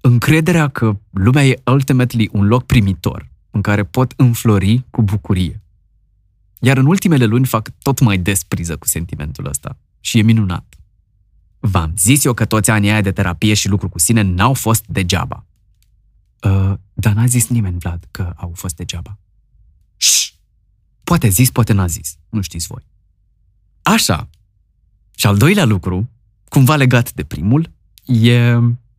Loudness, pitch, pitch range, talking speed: -15 LUFS, 105 Hz, 95-120 Hz, 150 wpm